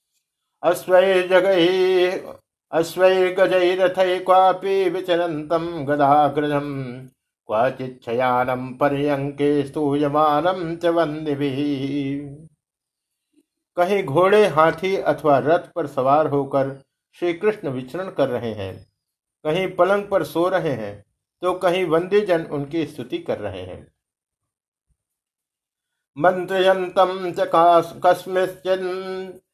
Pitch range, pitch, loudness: 145-185 Hz, 170 Hz, -20 LUFS